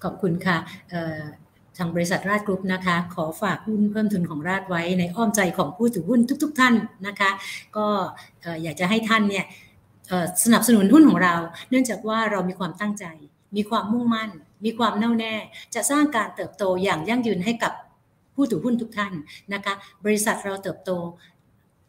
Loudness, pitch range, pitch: -23 LUFS, 175-220 Hz, 195 Hz